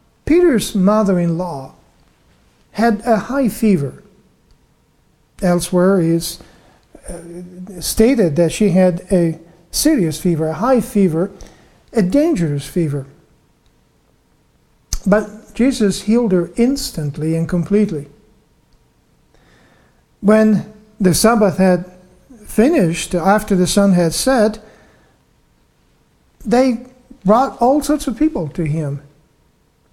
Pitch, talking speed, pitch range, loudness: 195 Hz, 90 wpm, 170-225 Hz, -16 LUFS